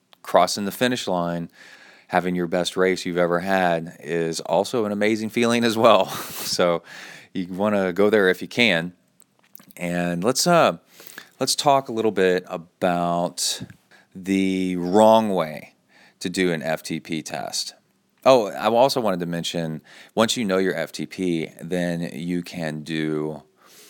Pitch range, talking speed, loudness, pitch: 85-95 Hz, 150 wpm, -22 LUFS, 90 Hz